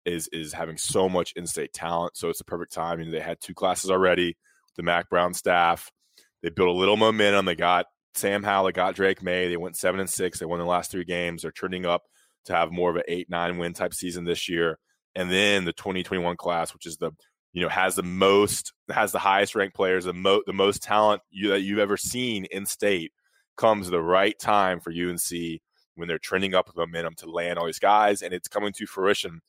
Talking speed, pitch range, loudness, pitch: 235 wpm, 85-95 Hz, -25 LUFS, 90 Hz